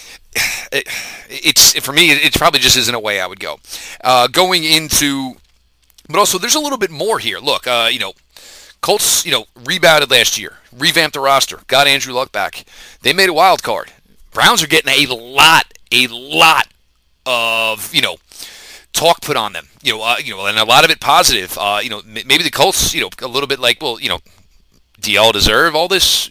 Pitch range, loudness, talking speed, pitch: 105-155 Hz, -12 LUFS, 210 wpm, 130 Hz